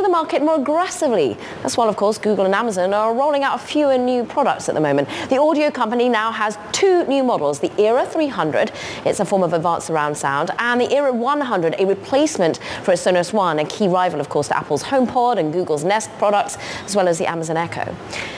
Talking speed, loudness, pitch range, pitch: 220 wpm, -19 LUFS, 180-270 Hz, 215 Hz